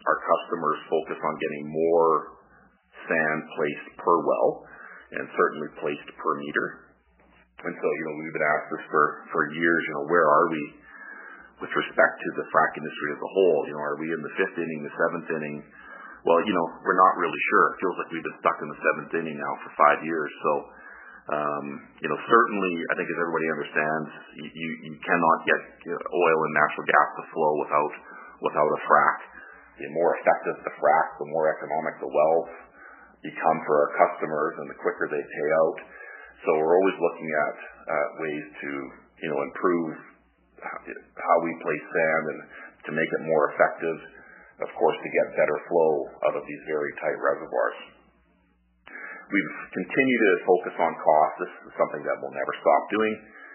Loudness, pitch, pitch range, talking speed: -25 LUFS, 75 Hz, 75-80 Hz, 185 wpm